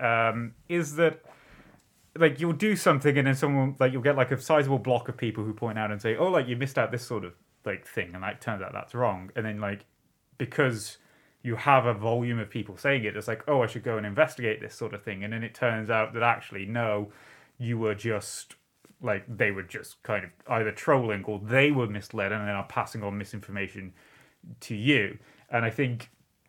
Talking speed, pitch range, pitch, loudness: 220 wpm, 105-135 Hz, 115 Hz, -28 LUFS